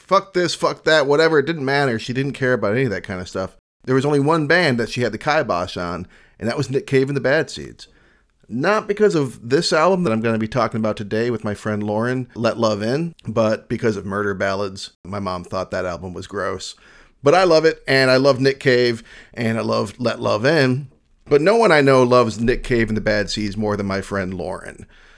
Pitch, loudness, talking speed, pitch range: 115 Hz, -19 LUFS, 245 wpm, 105-135 Hz